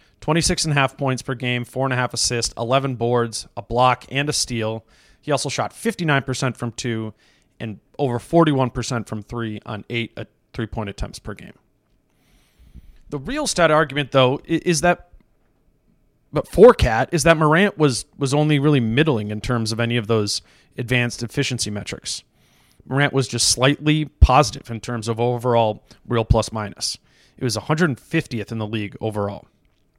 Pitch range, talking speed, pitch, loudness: 110-140 Hz, 170 wpm, 125 Hz, -20 LUFS